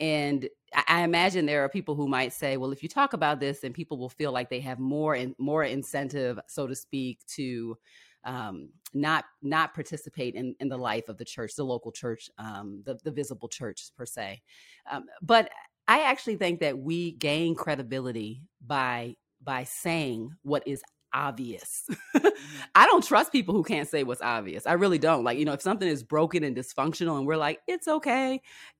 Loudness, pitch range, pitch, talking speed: -28 LUFS, 130-160 Hz, 145 Hz, 195 wpm